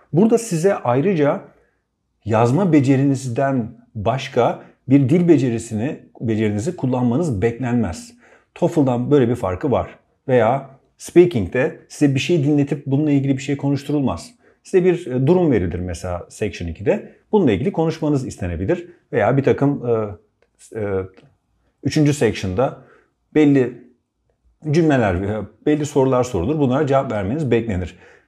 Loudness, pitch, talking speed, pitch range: -19 LUFS, 135 Hz, 115 wpm, 115-150 Hz